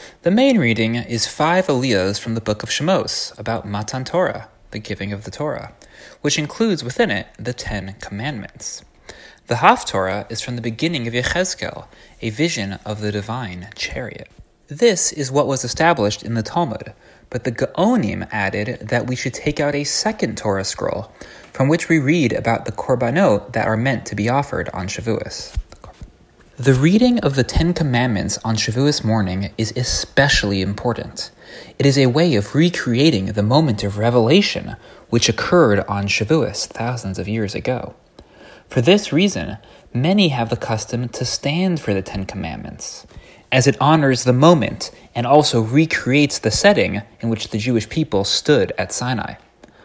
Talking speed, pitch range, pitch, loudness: 165 wpm, 105-150 Hz, 120 Hz, -18 LUFS